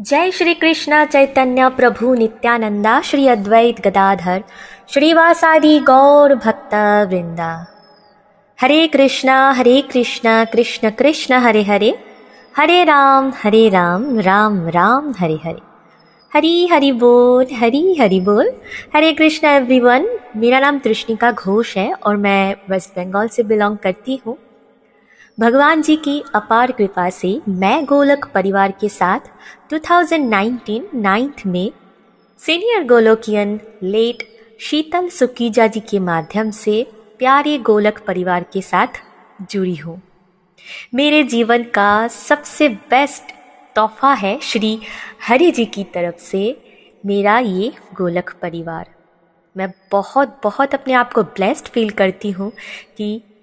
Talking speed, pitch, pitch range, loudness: 120 wpm, 225 Hz, 200-270 Hz, -14 LUFS